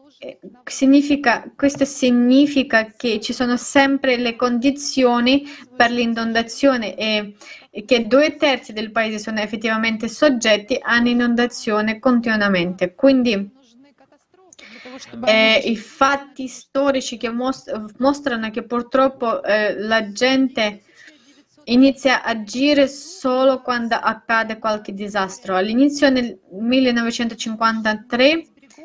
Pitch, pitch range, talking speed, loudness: 245 Hz, 225-270 Hz, 95 wpm, -18 LUFS